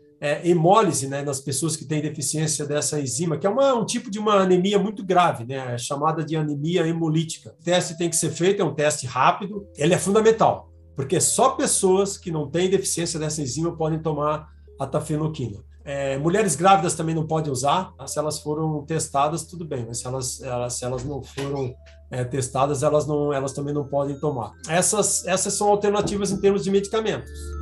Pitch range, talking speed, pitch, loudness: 140-185 Hz, 195 wpm, 155 Hz, -23 LUFS